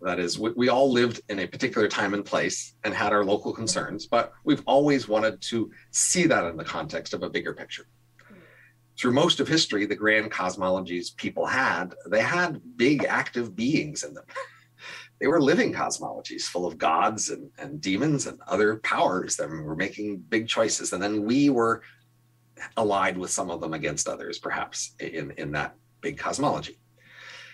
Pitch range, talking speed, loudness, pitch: 105-125 Hz, 175 wpm, -26 LUFS, 110 Hz